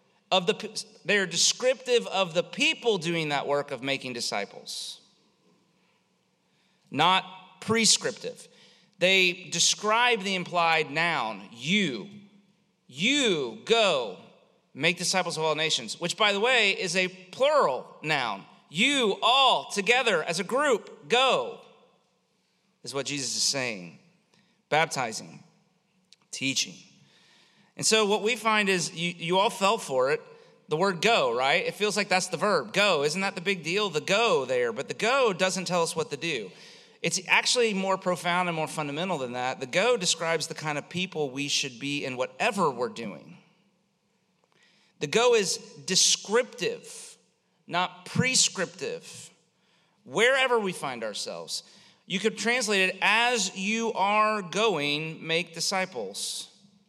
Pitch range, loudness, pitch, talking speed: 165-220 Hz, -25 LUFS, 190 Hz, 140 wpm